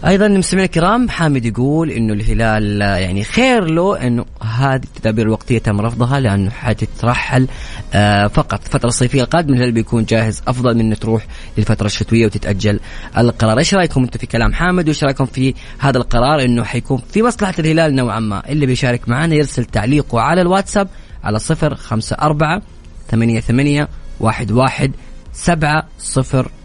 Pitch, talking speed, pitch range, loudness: 125 Hz, 150 wpm, 110-150 Hz, -15 LUFS